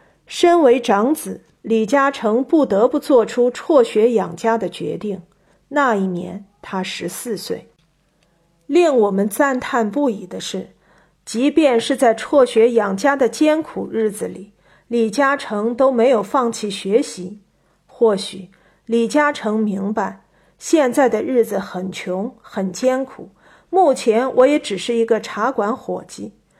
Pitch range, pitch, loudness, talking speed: 200-265 Hz, 230 Hz, -18 LUFS, 200 characters per minute